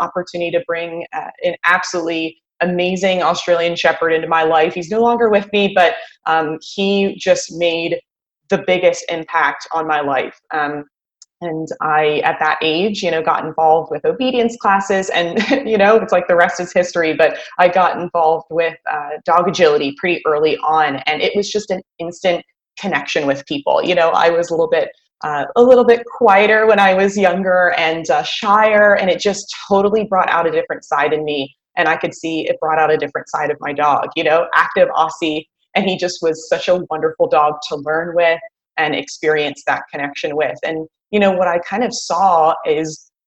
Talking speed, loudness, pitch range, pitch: 195 wpm, -16 LUFS, 160-195 Hz, 170 Hz